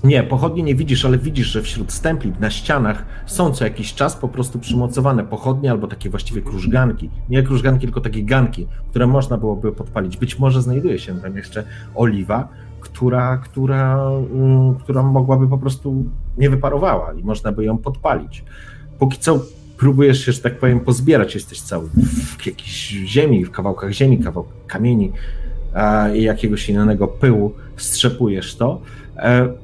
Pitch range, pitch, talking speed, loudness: 105-135 Hz, 120 Hz, 150 wpm, -18 LUFS